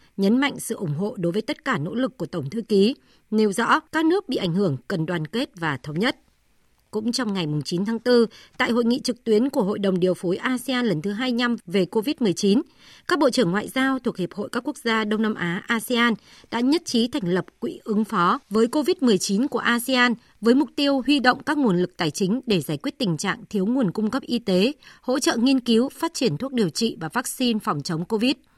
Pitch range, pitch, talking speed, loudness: 195-255 Hz, 225 Hz, 235 wpm, -23 LUFS